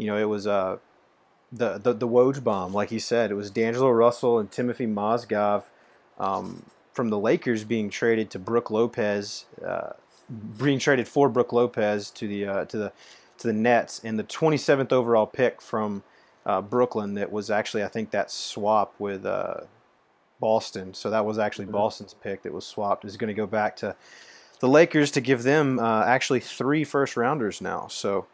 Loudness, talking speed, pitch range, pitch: -25 LUFS, 185 wpm, 105-125 Hz, 115 Hz